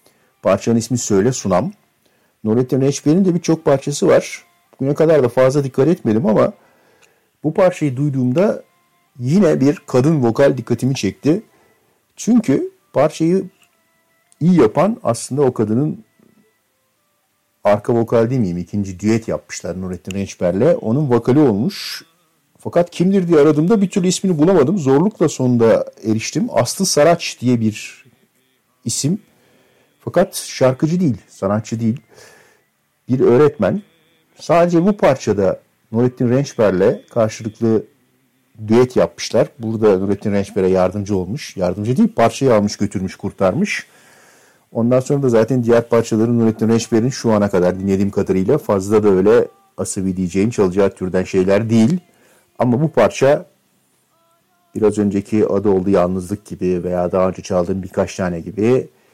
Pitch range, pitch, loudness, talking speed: 105-150 Hz, 120 Hz, -16 LUFS, 125 wpm